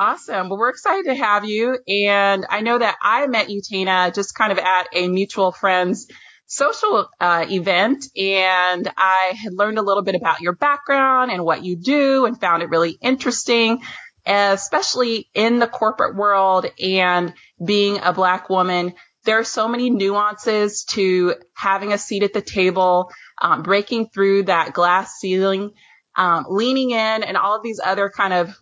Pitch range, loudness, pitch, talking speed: 185-225 Hz, -18 LUFS, 200 Hz, 170 wpm